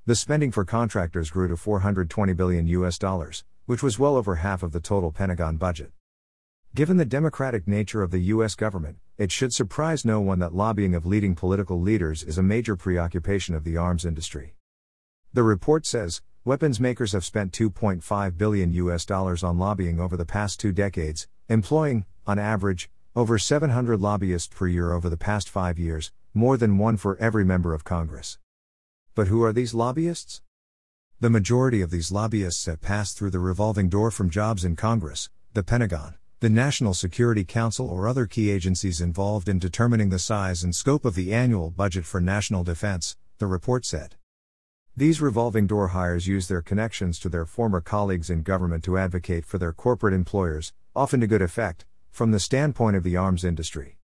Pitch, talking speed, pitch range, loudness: 95 Hz, 180 wpm, 85-110 Hz, -25 LUFS